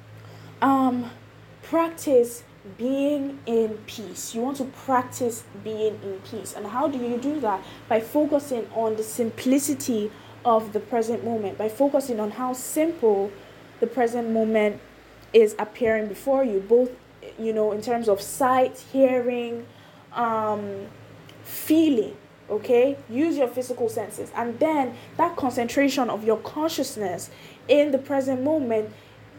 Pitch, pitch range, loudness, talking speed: 240 Hz, 215-270 Hz, -24 LUFS, 135 wpm